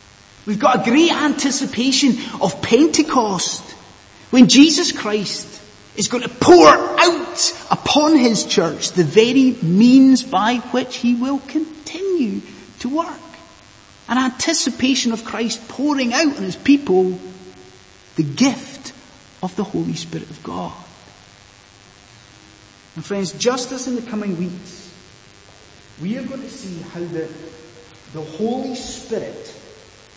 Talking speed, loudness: 125 wpm, -16 LUFS